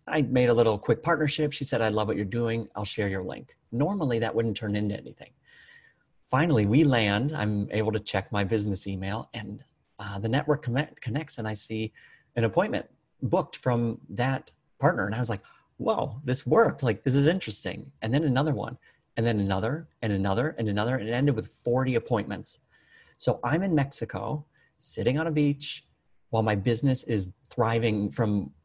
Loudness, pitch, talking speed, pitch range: -27 LUFS, 115 Hz, 190 wpm, 105-140 Hz